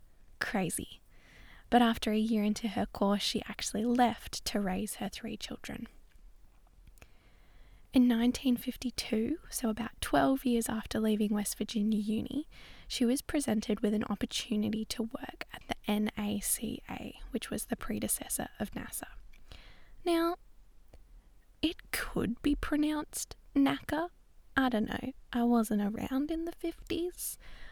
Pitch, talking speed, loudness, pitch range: 235 Hz, 130 wpm, -33 LUFS, 215-270 Hz